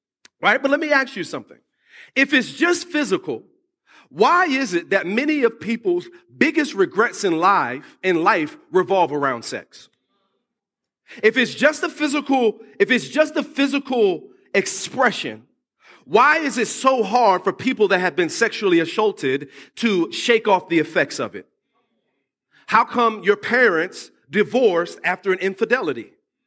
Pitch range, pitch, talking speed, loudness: 200-300 Hz, 245 Hz, 145 wpm, -19 LUFS